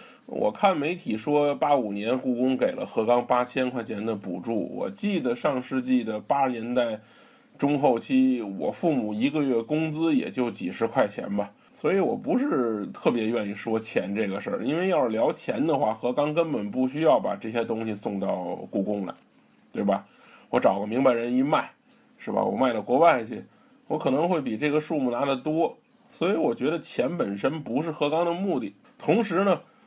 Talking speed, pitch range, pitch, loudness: 275 characters per minute, 115-160 Hz, 130 Hz, -26 LUFS